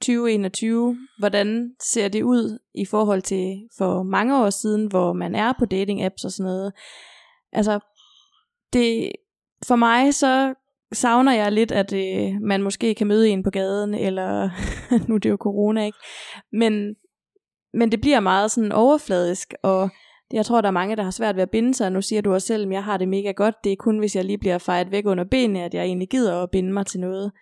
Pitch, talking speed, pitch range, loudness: 210 Hz, 210 wpm, 195-235 Hz, -21 LUFS